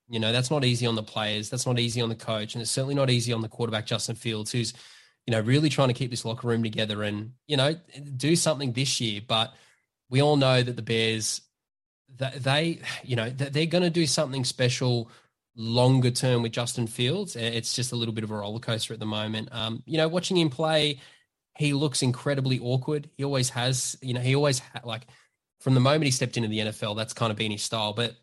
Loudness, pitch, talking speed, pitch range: -26 LUFS, 125 Hz, 235 wpm, 115-135 Hz